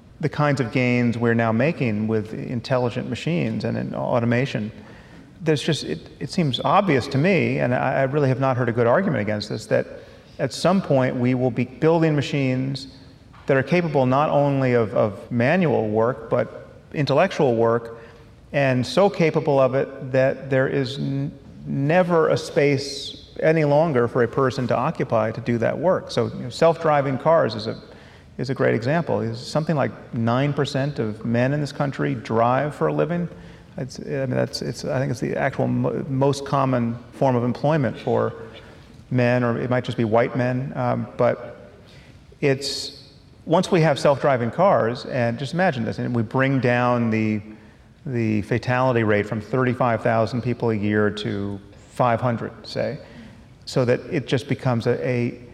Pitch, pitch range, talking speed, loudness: 125 Hz, 115-140 Hz, 175 wpm, -22 LUFS